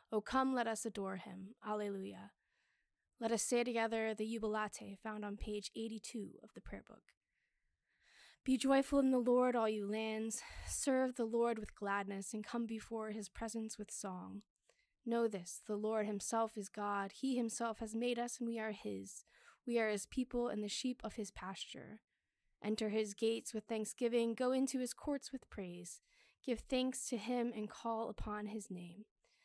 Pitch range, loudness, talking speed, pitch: 210-240 Hz, -40 LUFS, 175 wpm, 225 Hz